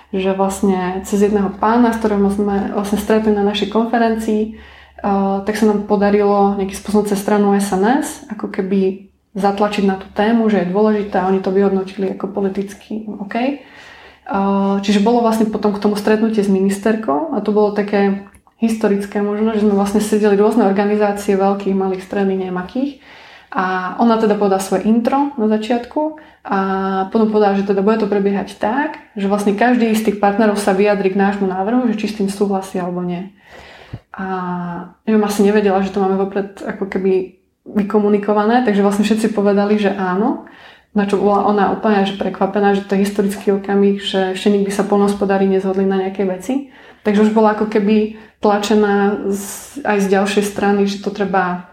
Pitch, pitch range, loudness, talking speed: 205 Hz, 195-215 Hz, -16 LUFS, 175 wpm